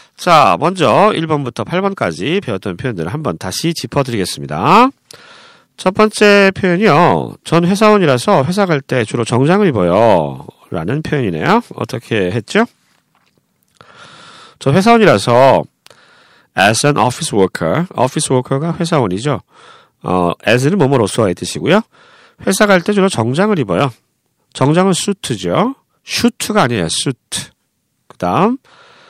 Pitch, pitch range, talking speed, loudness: 175 Hz, 130-210 Hz, 310 characters per minute, -13 LUFS